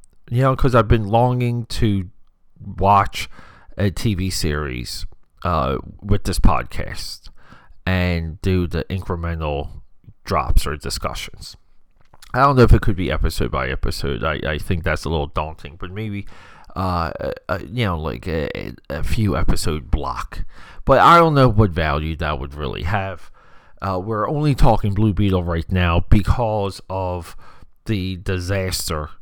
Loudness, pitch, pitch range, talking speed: -20 LUFS, 95 Hz, 80-105 Hz, 150 wpm